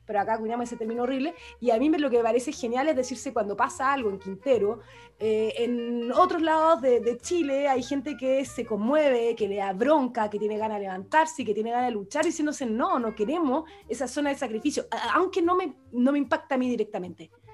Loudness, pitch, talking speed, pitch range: -26 LUFS, 250 Hz, 230 wpm, 220-295 Hz